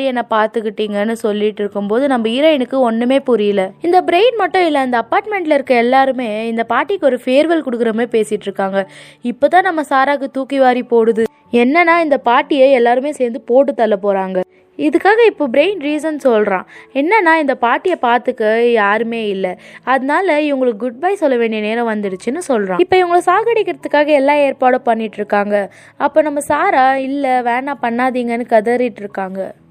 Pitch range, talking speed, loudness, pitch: 225-295 Hz, 145 wpm, -14 LUFS, 255 Hz